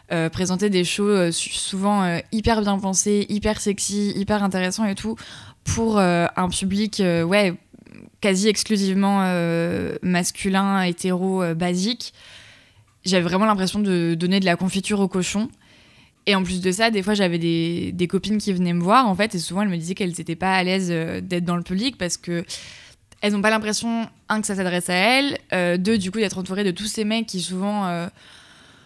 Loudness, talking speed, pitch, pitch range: -21 LUFS, 200 wpm, 190 Hz, 175-210 Hz